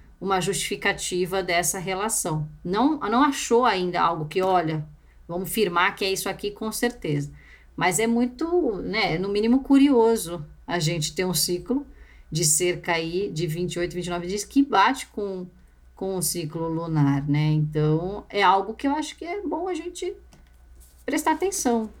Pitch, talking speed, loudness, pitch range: 190 Hz, 160 wpm, -24 LUFS, 170-235 Hz